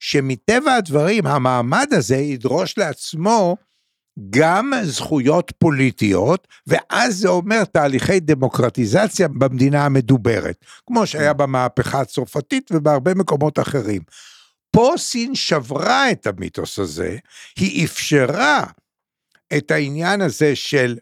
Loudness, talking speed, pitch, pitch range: -18 LUFS, 100 wpm, 150 Hz, 135-190 Hz